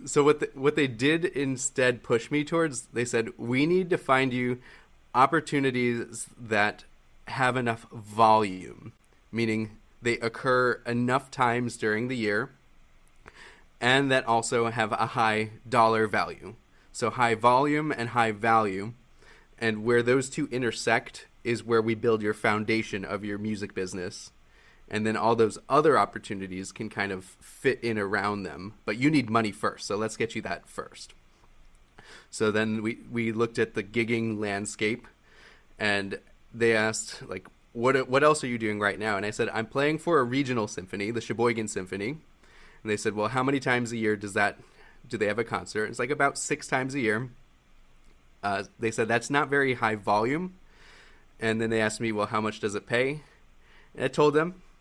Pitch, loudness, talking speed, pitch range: 115 Hz, -27 LUFS, 180 wpm, 105-130 Hz